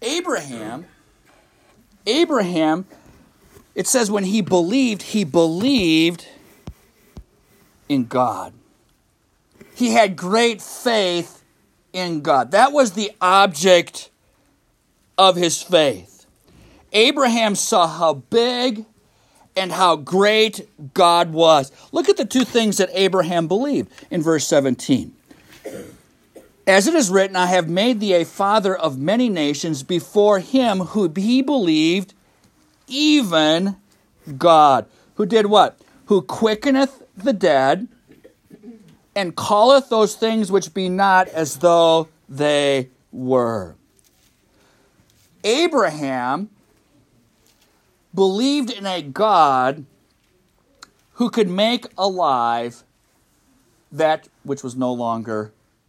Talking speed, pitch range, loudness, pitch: 105 wpm, 165-230 Hz, -18 LUFS, 195 Hz